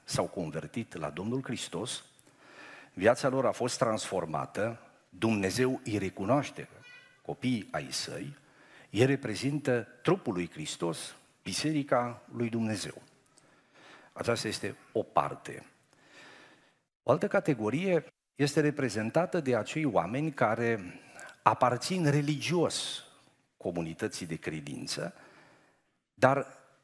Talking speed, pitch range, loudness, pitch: 95 wpm, 105-140 Hz, -31 LUFS, 120 Hz